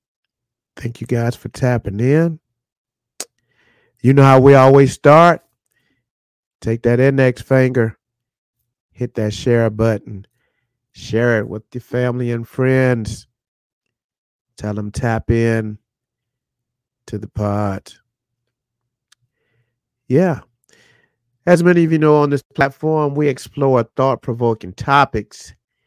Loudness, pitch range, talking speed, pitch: -15 LUFS, 115-130 Hz, 110 wpm, 120 Hz